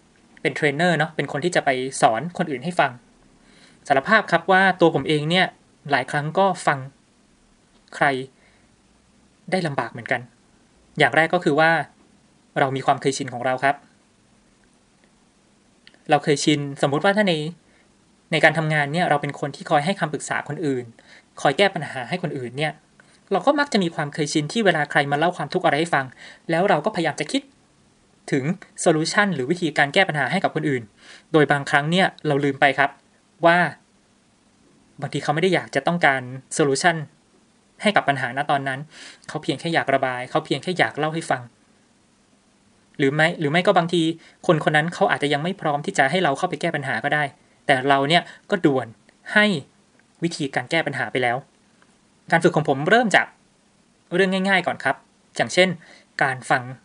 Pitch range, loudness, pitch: 140-180 Hz, -21 LUFS, 155 Hz